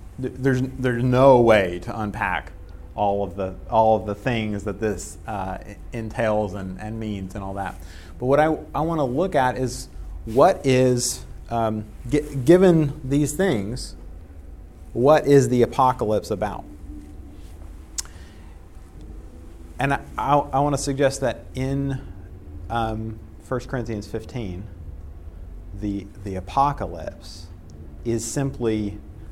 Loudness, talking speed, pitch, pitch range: -22 LUFS, 125 wpm, 105 Hz, 85-130 Hz